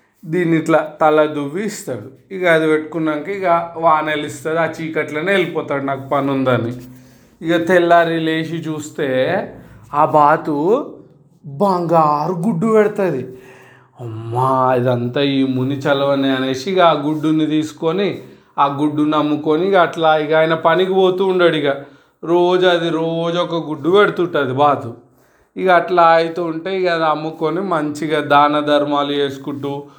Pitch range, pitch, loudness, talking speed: 140-170 Hz, 155 Hz, -16 LUFS, 120 wpm